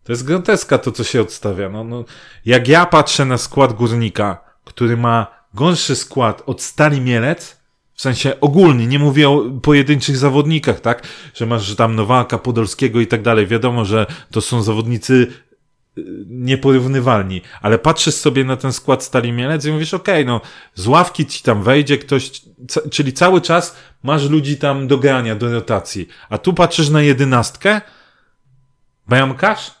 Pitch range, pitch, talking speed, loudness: 120-150 Hz, 130 Hz, 165 wpm, -15 LUFS